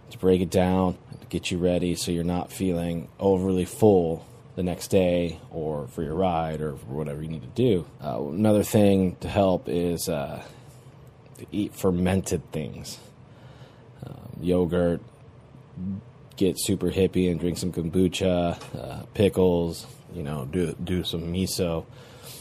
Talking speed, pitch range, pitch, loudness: 150 wpm, 85-110 Hz, 90 Hz, -26 LUFS